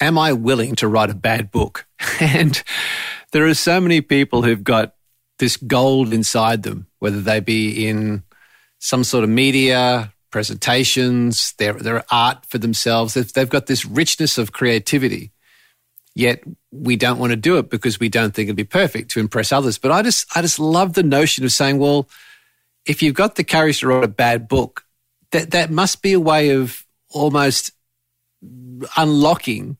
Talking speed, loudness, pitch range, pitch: 175 wpm, -17 LUFS, 115-150 Hz, 125 Hz